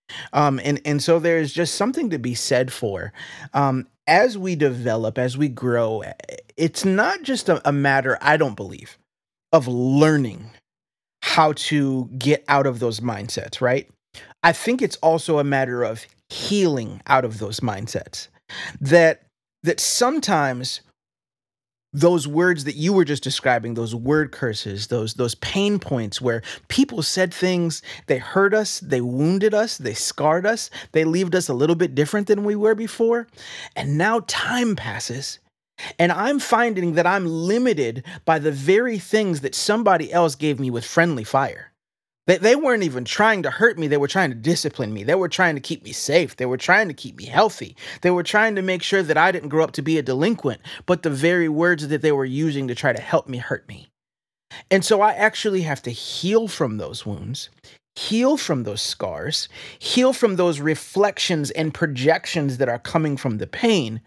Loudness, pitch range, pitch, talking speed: -20 LUFS, 130-190 Hz, 155 Hz, 185 wpm